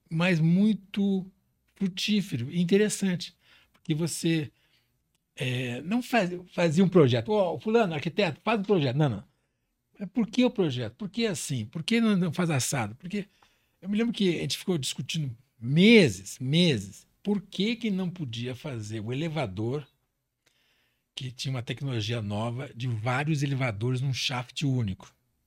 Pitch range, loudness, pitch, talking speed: 130-195 Hz, -27 LUFS, 160 Hz, 155 wpm